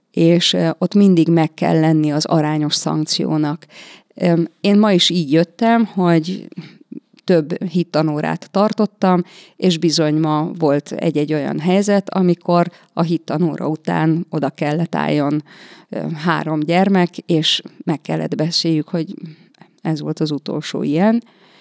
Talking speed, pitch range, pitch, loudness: 120 wpm, 155-185 Hz, 170 Hz, -17 LUFS